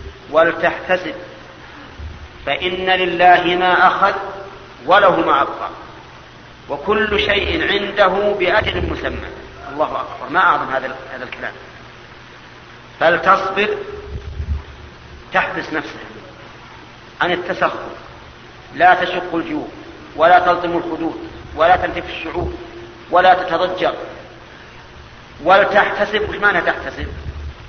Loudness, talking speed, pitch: -16 LUFS, 80 wpm, 180 Hz